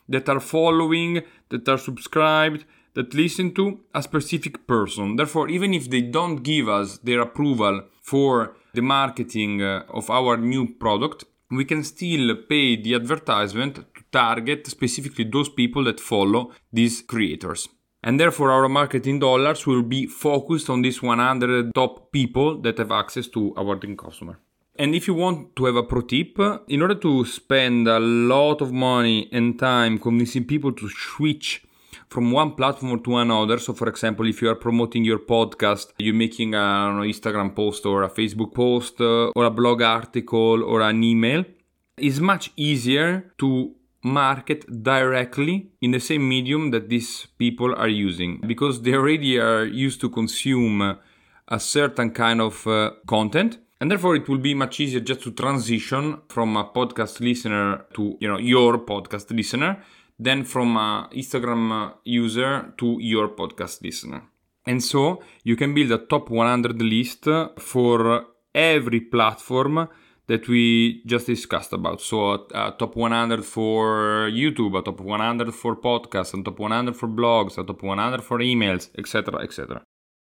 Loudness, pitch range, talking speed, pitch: -22 LUFS, 115-140 Hz, 160 wpm, 120 Hz